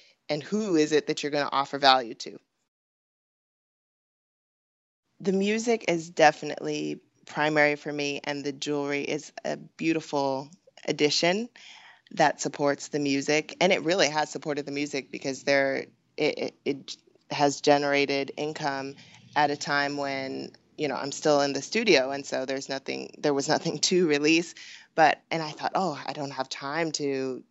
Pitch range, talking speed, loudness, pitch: 140-150 Hz, 160 wpm, -27 LUFS, 145 Hz